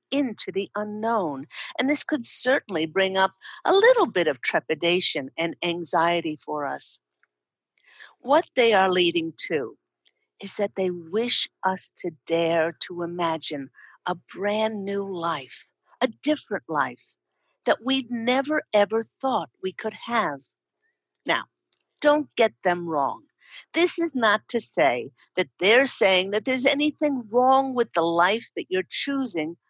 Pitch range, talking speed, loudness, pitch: 170-265 Hz, 140 wpm, -24 LUFS, 205 Hz